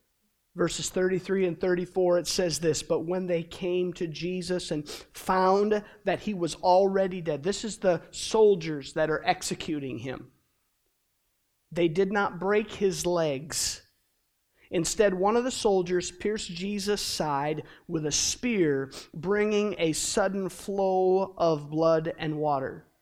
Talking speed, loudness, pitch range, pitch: 140 wpm, -27 LUFS, 165-195 Hz, 180 Hz